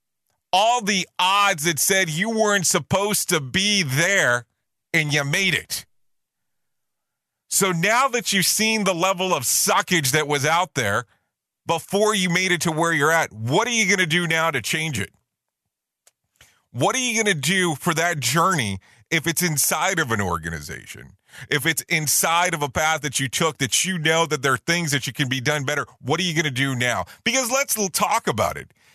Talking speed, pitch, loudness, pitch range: 195 wpm, 165 Hz, -20 LUFS, 145-190 Hz